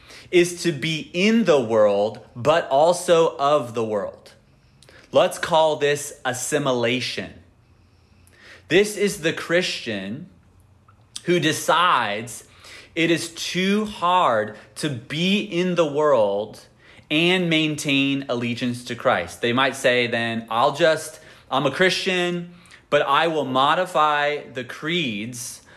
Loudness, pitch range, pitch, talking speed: -21 LUFS, 115-170 Hz, 140 Hz, 115 wpm